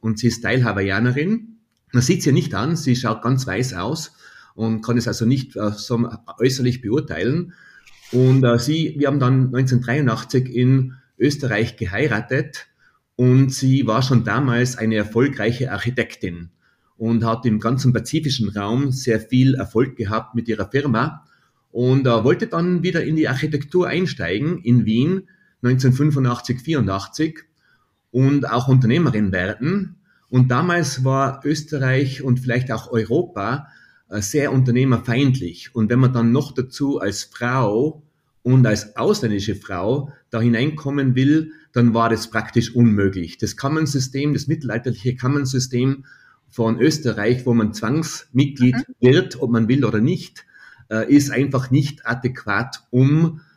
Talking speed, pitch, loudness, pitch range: 130 wpm, 125 Hz, -19 LUFS, 115-140 Hz